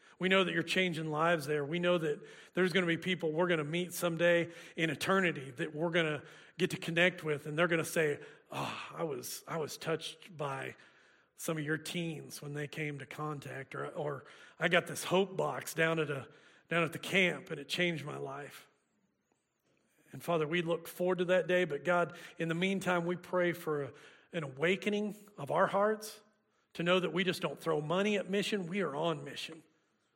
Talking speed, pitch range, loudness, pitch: 205 wpm, 155-180 Hz, -34 LUFS, 170 Hz